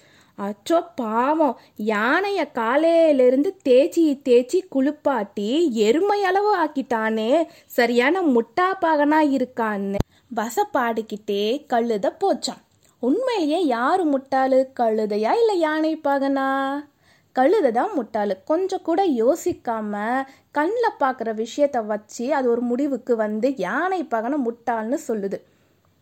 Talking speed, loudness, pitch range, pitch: 95 wpm, -21 LUFS, 230-315 Hz, 270 Hz